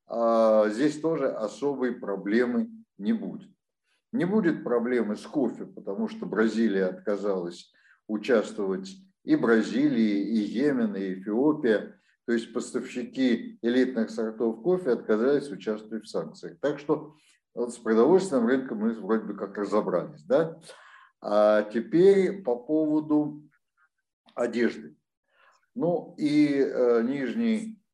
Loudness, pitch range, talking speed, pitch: -26 LUFS, 110-185 Hz, 115 wpm, 125 Hz